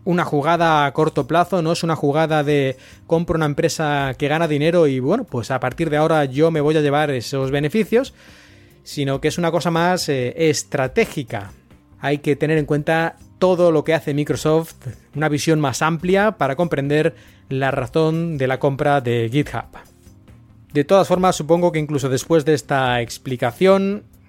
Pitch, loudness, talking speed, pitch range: 150 Hz, -19 LUFS, 175 wpm, 135-165 Hz